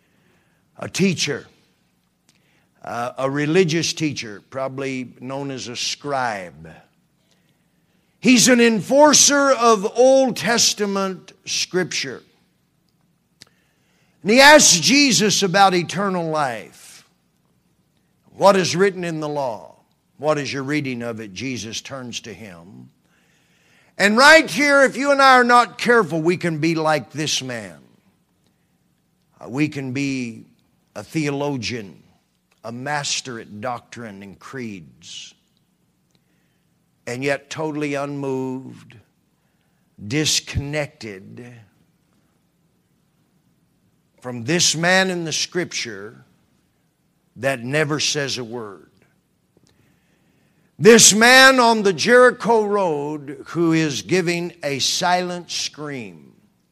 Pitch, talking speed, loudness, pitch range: 155 Hz, 105 wpm, -17 LUFS, 130-195 Hz